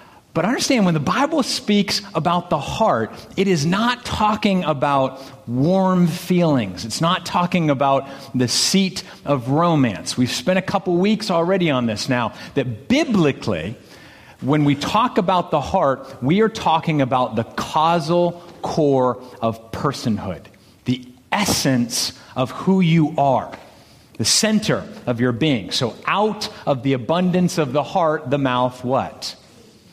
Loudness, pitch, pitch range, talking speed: -19 LUFS, 150 Hz, 125-185 Hz, 145 wpm